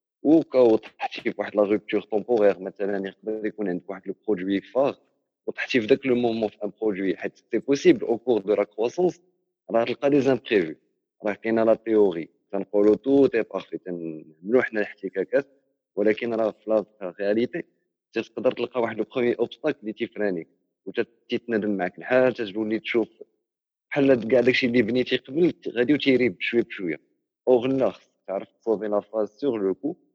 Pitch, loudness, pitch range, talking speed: 115 Hz, -24 LUFS, 105-130 Hz, 160 wpm